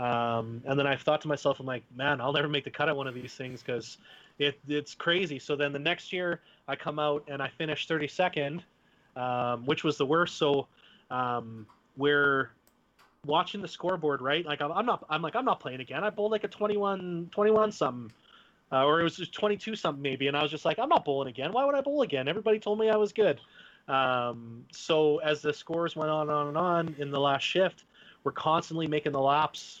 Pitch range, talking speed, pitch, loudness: 135-175 Hz, 230 wpm, 150 Hz, -29 LUFS